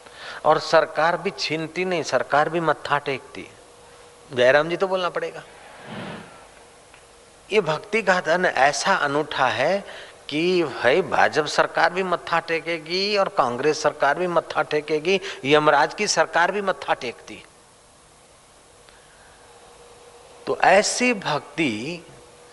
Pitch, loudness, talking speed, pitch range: 165 Hz, -21 LUFS, 115 wpm, 155-190 Hz